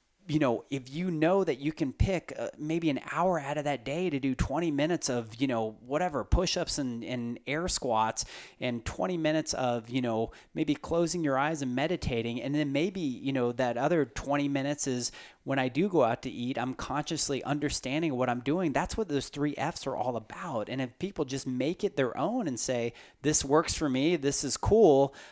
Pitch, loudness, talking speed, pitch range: 140 Hz, -30 LUFS, 215 wpm, 125-155 Hz